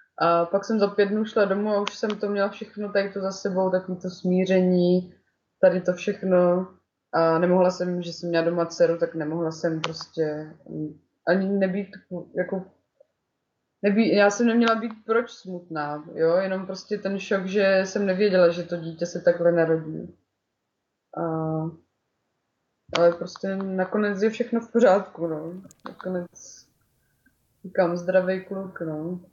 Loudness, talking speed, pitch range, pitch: -24 LUFS, 150 wpm, 170-200 Hz, 185 Hz